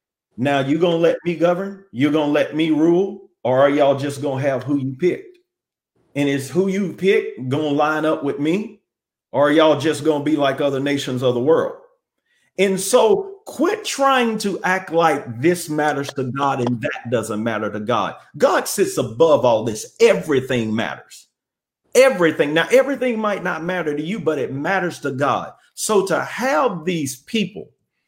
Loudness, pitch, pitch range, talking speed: -19 LUFS, 160 Hz, 140-205 Hz, 190 wpm